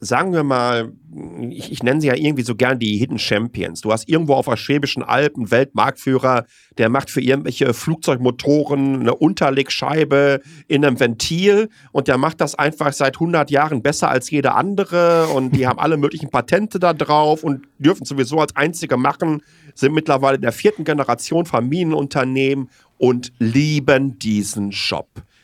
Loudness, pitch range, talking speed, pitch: -18 LUFS, 125-155 Hz, 165 wpm, 140 Hz